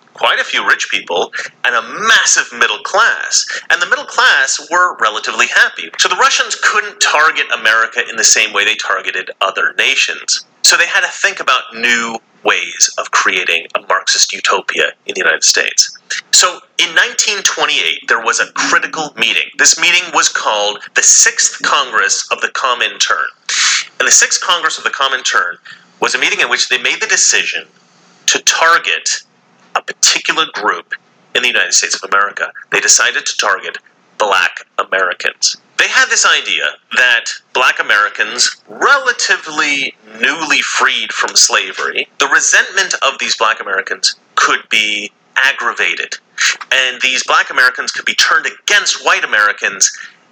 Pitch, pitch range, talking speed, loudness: 120 Hz, 110-180 Hz, 155 wpm, -11 LUFS